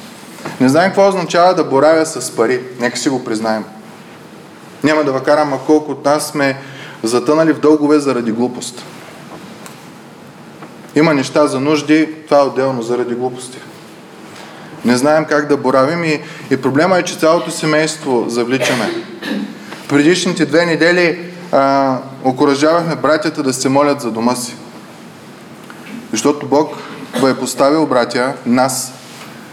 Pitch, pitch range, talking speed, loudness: 145 Hz, 130-155 Hz, 135 wpm, -14 LUFS